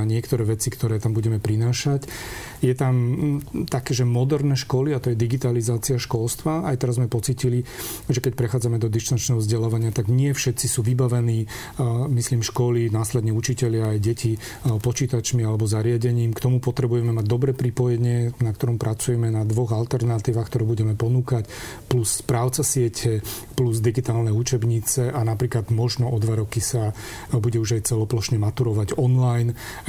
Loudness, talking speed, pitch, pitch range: -23 LUFS, 155 wpm, 120 Hz, 115-125 Hz